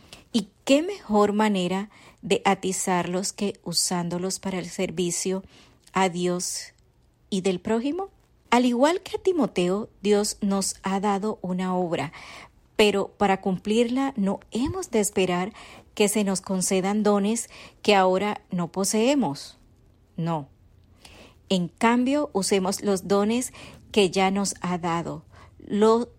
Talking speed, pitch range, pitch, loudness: 125 wpm, 185-215 Hz, 195 Hz, -25 LUFS